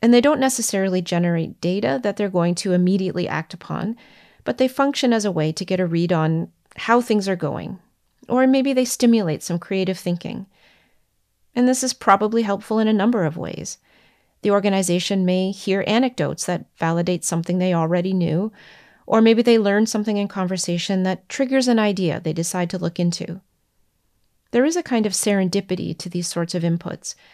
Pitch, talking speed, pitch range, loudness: 190 Hz, 180 wpm, 175-225 Hz, -20 LUFS